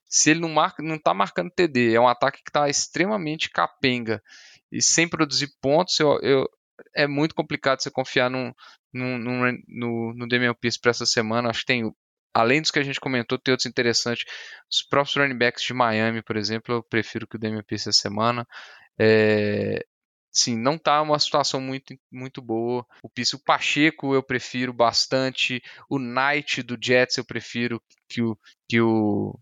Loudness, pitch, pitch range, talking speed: -23 LUFS, 125 Hz, 115-140 Hz, 175 wpm